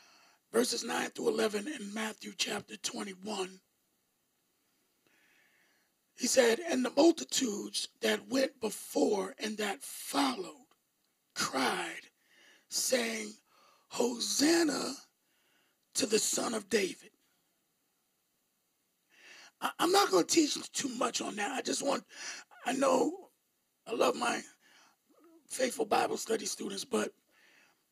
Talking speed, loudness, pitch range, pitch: 105 wpm, -32 LUFS, 220-320 Hz, 265 Hz